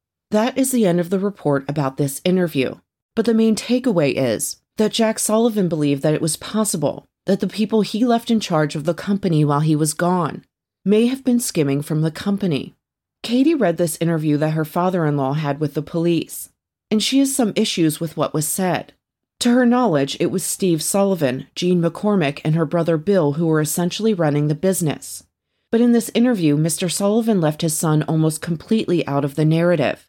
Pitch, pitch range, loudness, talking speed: 170 Hz, 155-215 Hz, -19 LUFS, 200 wpm